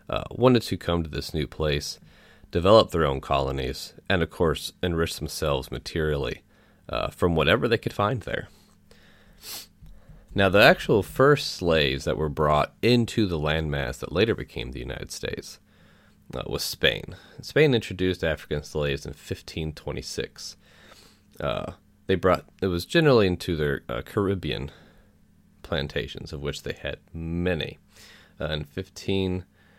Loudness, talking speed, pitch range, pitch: -25 LUFS, 145 wpm, 75-95 Hz, 80 Hz